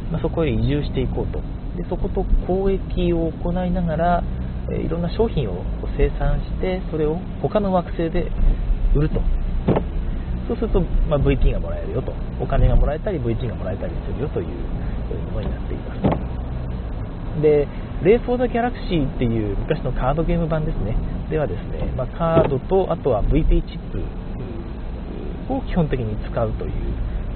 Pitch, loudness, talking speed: 140 Hz, -23 LUFS, 345 characters per minute